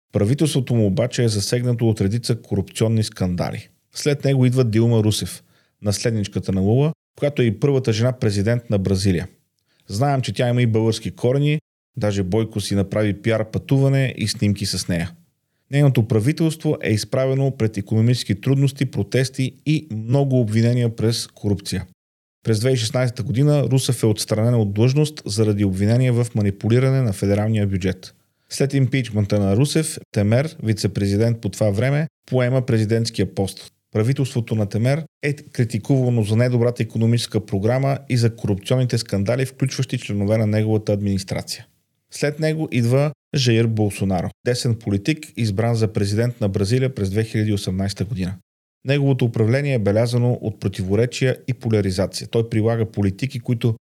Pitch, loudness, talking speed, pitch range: 115 Hz, -20 LUFS, 140 wpm, 105-130 Hz